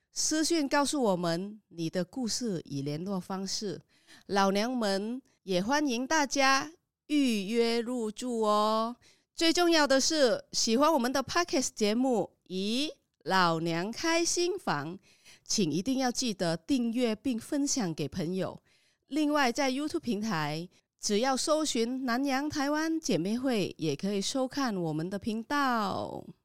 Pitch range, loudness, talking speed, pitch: 195-280 Hz, -30 LUFS, 225 characters per minute, 235 Hz